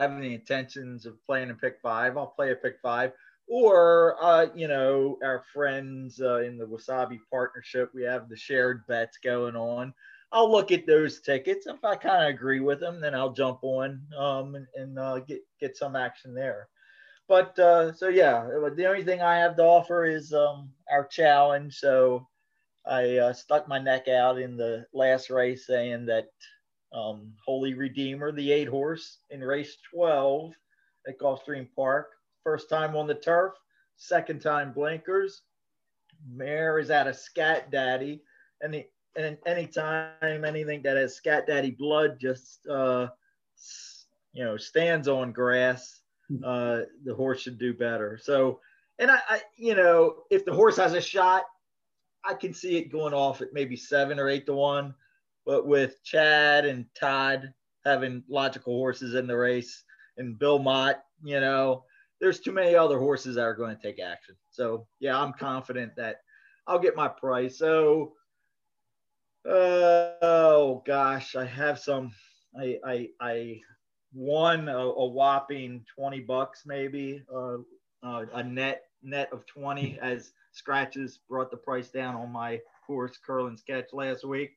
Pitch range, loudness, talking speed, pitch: 130-155 Hz, -26 LUFS, 165 wpm, 135 Hz